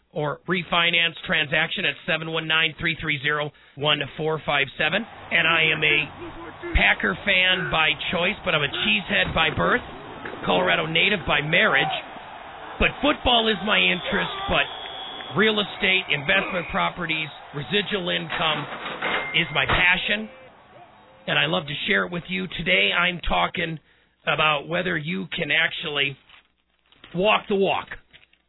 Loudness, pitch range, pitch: -21 LUFS, 155-190 Hz, 170 Hz